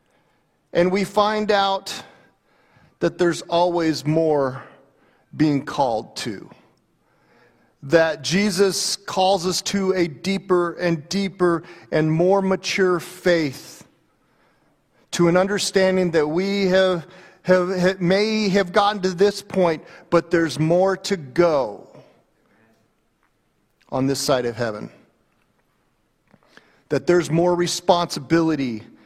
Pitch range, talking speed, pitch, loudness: 160-190 Hz, 105 wpm, 175 Hz, -20 LUFS